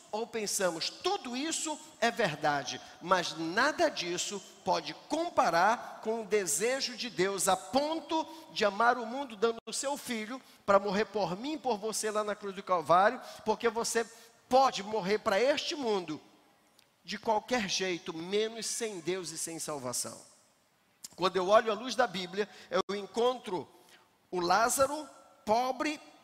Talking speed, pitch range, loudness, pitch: 150 wpm, 190-250 Hz, -31 LUFS, 220 Hz